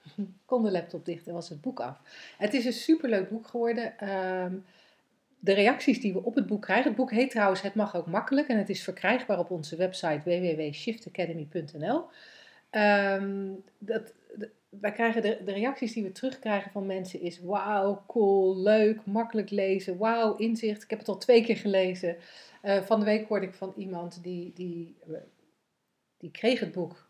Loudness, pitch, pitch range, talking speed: -29 LUFS, 200 Hz, 185-225 Hz, 165 wpm